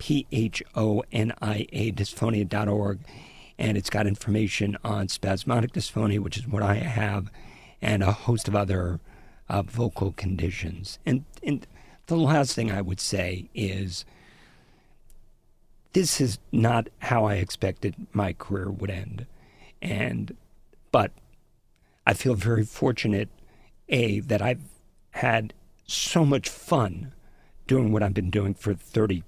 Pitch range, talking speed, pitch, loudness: 100-115 Hz, 135 wpm, 105 Hz, -27 LUFS